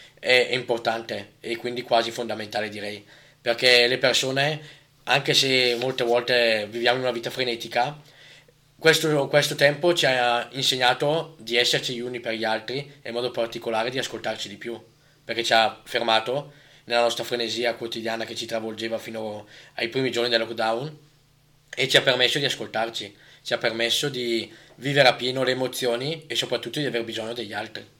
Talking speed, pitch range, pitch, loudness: 170 wpm, 115-140 Hz, 120 Hz, -23 LUFS